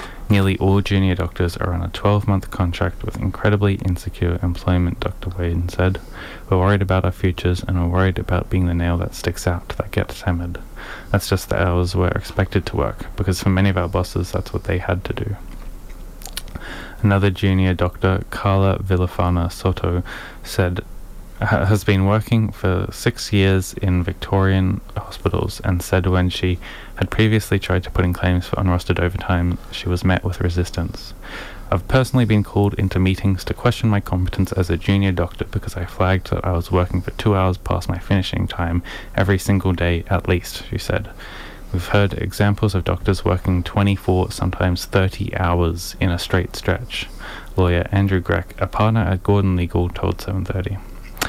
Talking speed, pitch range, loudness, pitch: 175 wpm, 90-100 Hz, -20 LUFS, 95 Hz